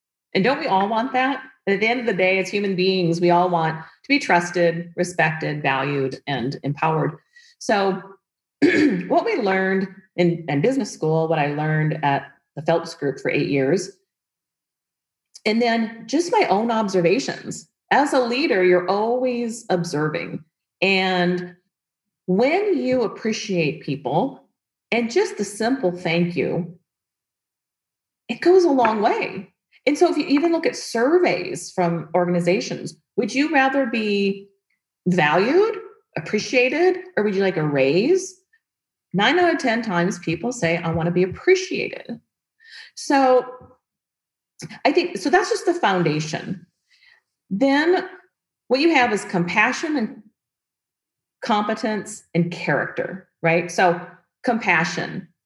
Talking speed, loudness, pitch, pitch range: 135 wpm, -21 LUFS, 195 Hz, 170-260 Hz